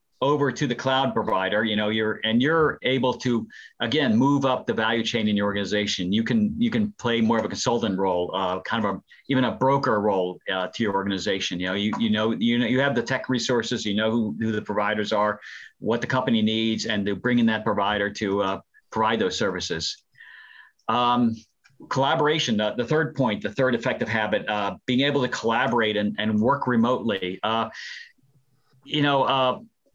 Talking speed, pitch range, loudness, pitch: 200 wpm, 105-130 Hz, -24 LUFS, 115 Hz